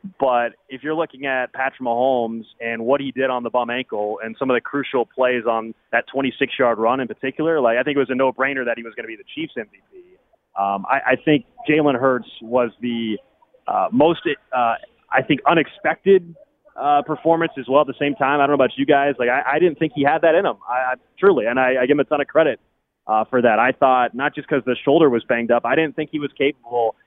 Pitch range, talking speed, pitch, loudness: 120-150 Hz, 255 wpm, 135 Hz, -19 LUFS